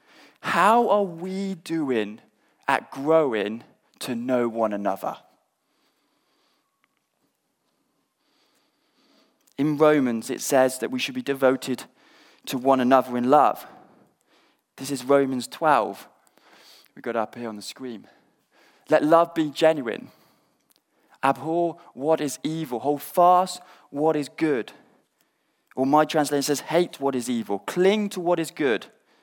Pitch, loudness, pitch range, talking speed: 145 Hz, -23 LUFS, 130-165 Hz, 125 wpm